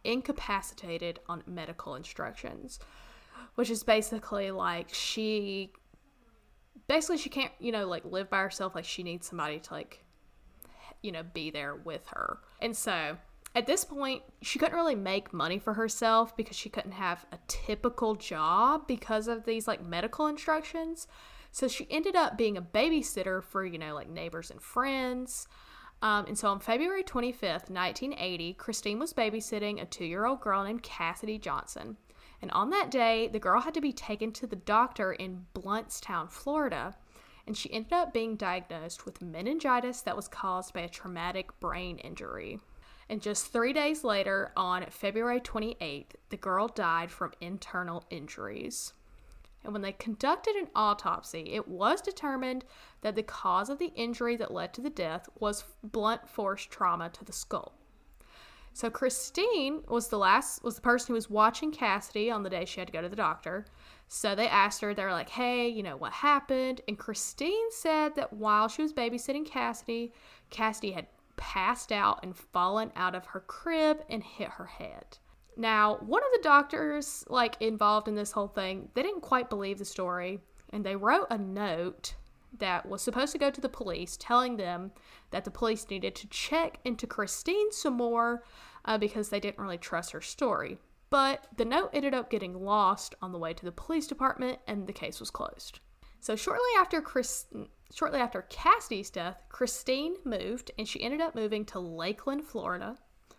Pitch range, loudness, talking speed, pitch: 195-260 Hz, -32 LUFS, 175 wpm, 220 Hz